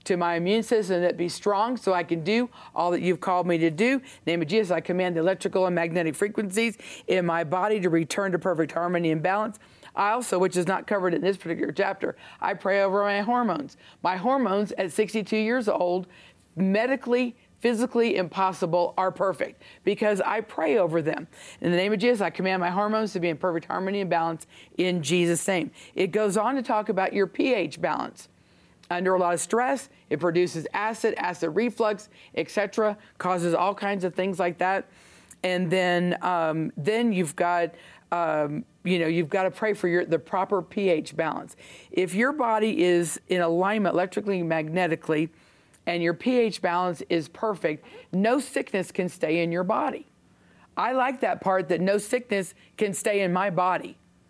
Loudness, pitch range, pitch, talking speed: -26 LUFS, 175-210 Hz, 185 Hz, 185 wpm